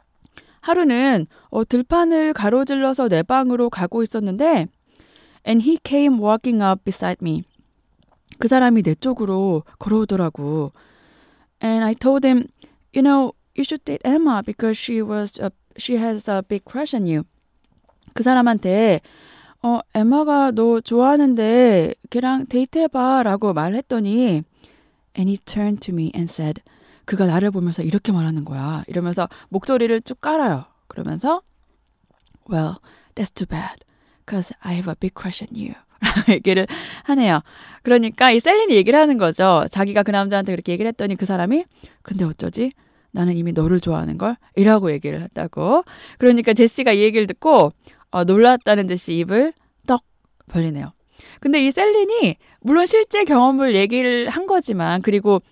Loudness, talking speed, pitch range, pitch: -18 LUFS, 400 characters per minute, 185-255 Hz, 220 Hz